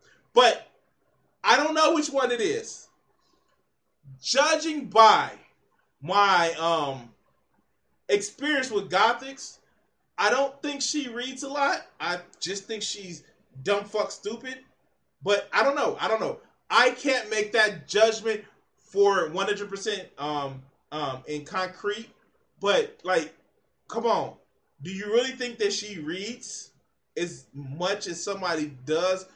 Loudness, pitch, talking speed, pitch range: -25 LUFS, 205 Hz, 130 wpm, 175-260 Hz